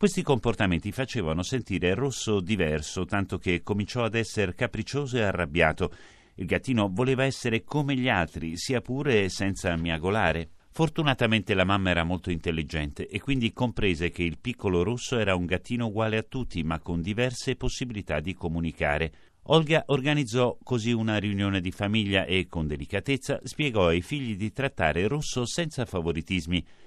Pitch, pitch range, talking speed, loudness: 105 Hz, 90-125 Hz, 150 wpm, -27 LUFS